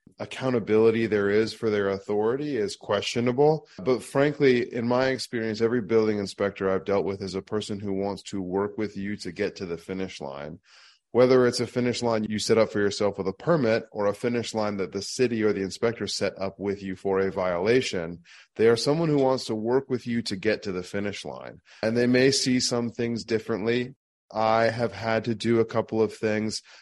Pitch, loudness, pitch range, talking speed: 110 Hz, -26 LUFS, 100-120 Hz, 215 wpm